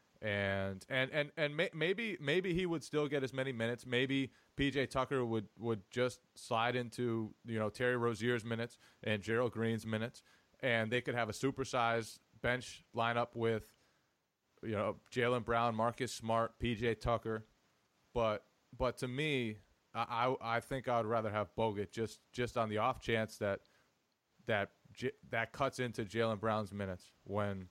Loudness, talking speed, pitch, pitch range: -37 LUFS, 165 wpm, 115 Hz, 110-130 Hz